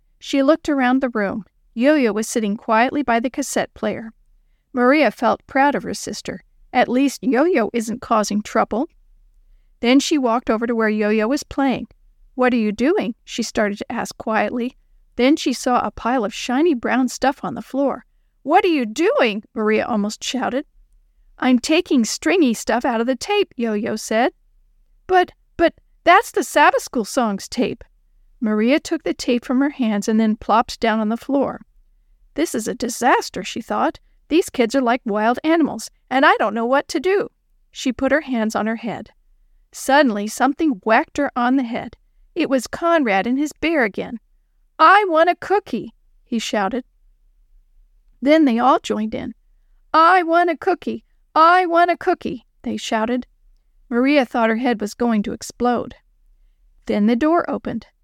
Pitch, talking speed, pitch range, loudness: 255 Hz, 175 wpm, 225-300 Hz, -19 LUFS